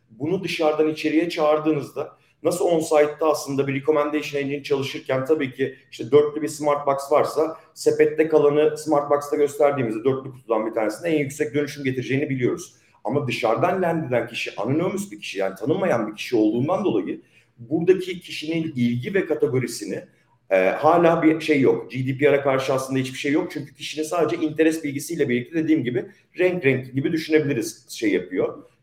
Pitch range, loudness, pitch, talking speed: 135-160 Hz, -22 LUFS, 150 Hz, 160 wpm